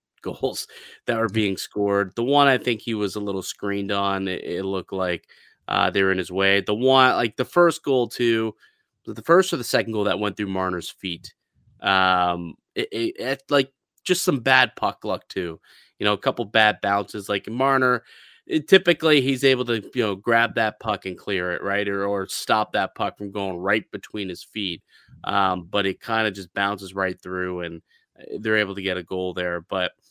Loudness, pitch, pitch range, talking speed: -23 LUFS, 105 Hz, 95-120 Hz, 205 wpm